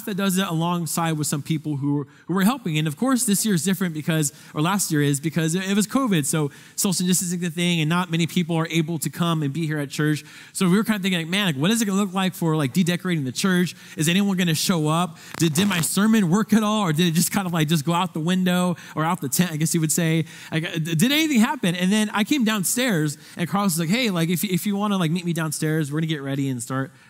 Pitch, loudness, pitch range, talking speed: 175 Hz, -22 LUFS, 160-195 Hz, 290 wpm